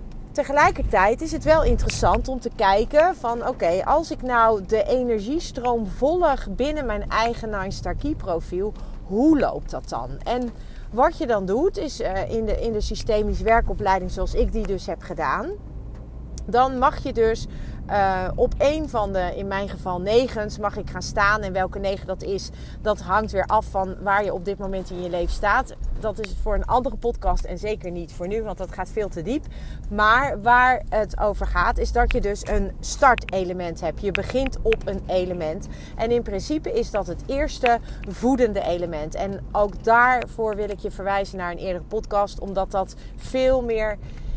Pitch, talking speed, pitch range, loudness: 210 Hz, 190 wpm, 190-245 Hz, -23 LUFS